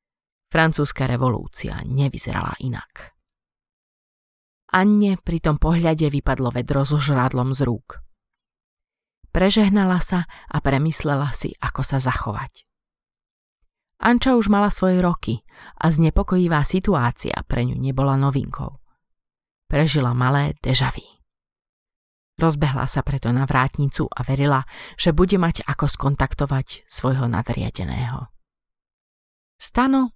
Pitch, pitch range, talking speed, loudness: 140 Hz, 130-165 Hz, 105 wpm, -19 LUFS